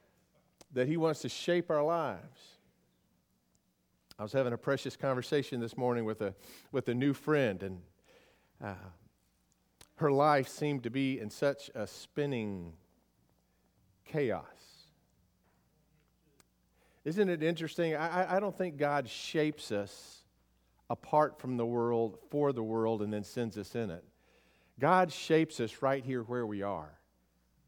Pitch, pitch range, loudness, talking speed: 120 Hz, 95-145 Hz, -34 LUFS, 140 wpm